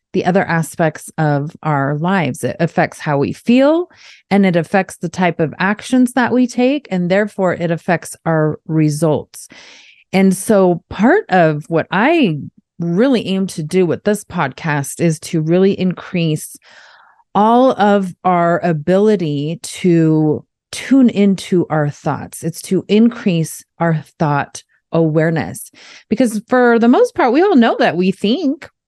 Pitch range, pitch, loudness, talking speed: 160-210 Hz, 180 Hz, -15 LUFS, 145 wpm